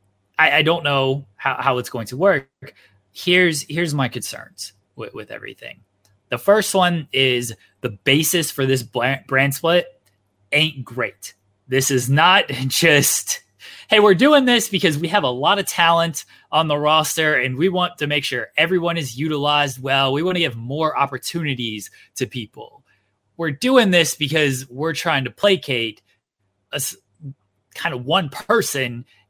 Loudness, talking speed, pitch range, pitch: -18 LUFS, 155 wpm, 125-170 Hz, 140 Hz